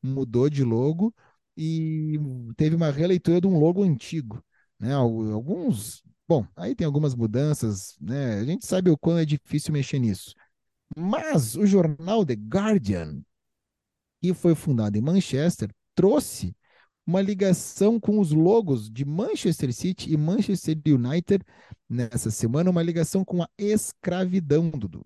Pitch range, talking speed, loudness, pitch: 125-180 Hz, 140 wpm, -24 LUFS, 155 Hz